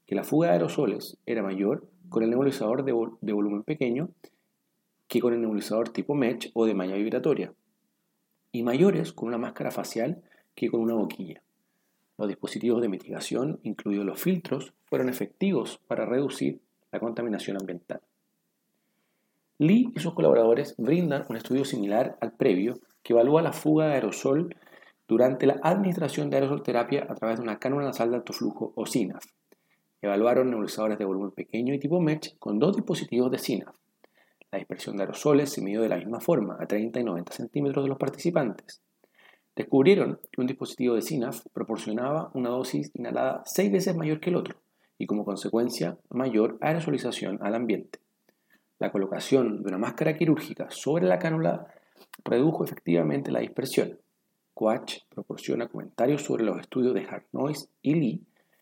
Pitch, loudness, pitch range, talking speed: 120 Hz, -27 LUFS, 110-145 Hz, 165 wpm